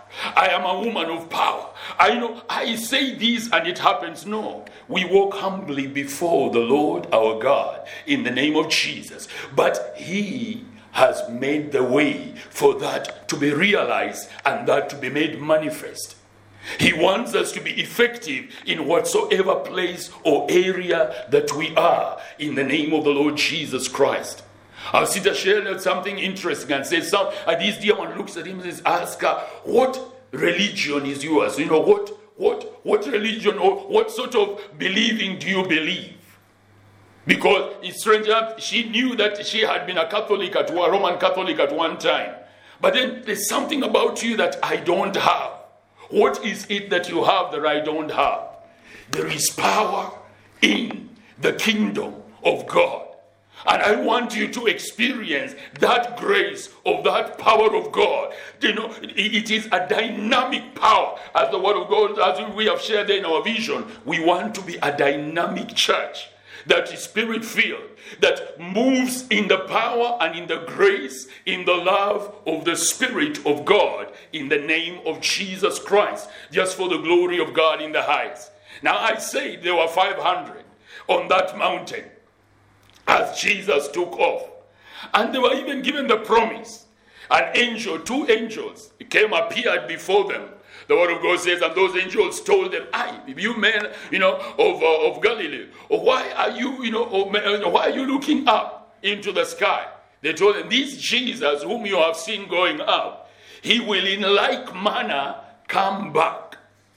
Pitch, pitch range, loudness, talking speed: 215 Hz, 175-270 Hz, -21 LUFS, 170 wpm